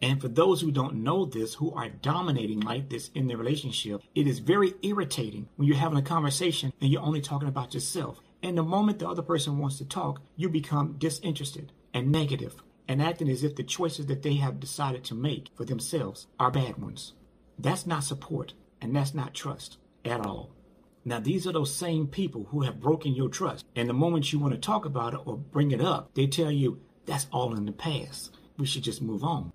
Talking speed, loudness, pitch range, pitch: 215 wpm, -29 LUFS, 130-160 Hz, 145 Hz